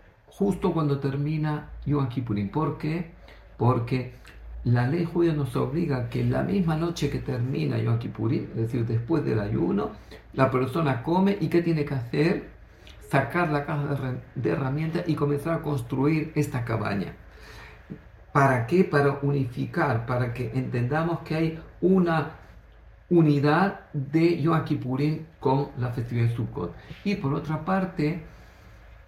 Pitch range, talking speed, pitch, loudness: 125-160 Hz, 140 wpm, 145 Hz, -26 LUFS